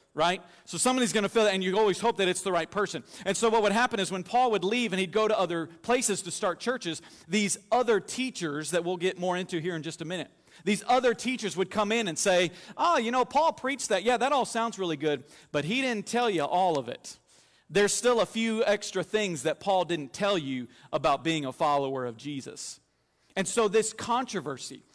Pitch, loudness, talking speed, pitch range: 195 Hz, -28 LUFS, 230 wpm, 170-230 Hz